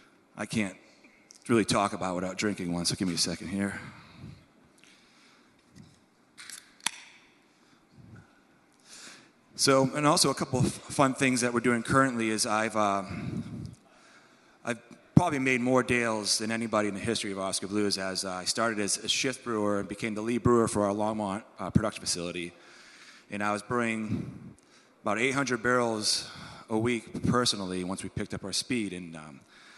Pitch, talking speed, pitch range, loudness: 105 Hz, 160 wpm, 95-120 Hz, -28 LUFS